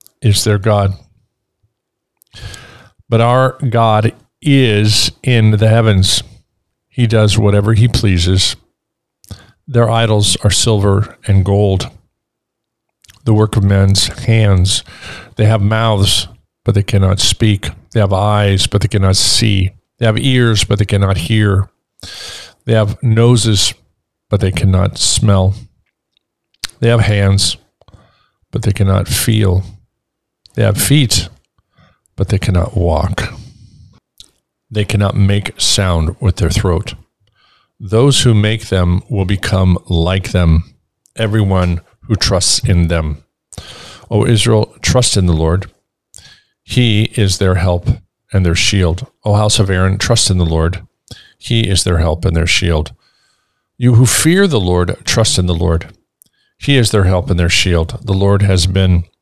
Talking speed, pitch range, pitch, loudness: 140 wpm, 95-110 Hz, 100 Hz, -13 LUFS